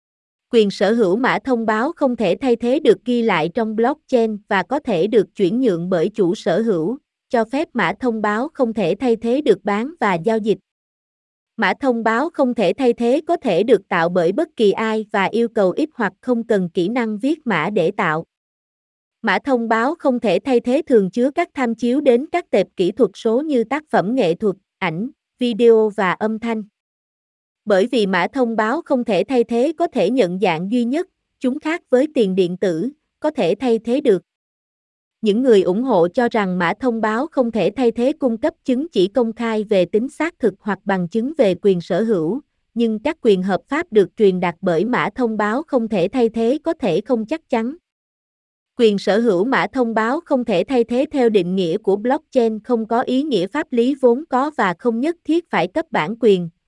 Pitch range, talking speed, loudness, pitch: 205-260 Hz, 215 wpm, -18 LUFS, 230 Hz